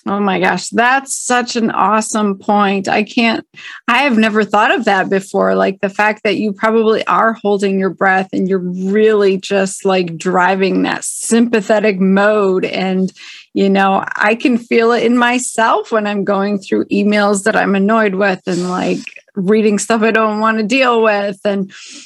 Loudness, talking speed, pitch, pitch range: -14 LUFS, 175 wpm, 210 Hz, 195-225 Hz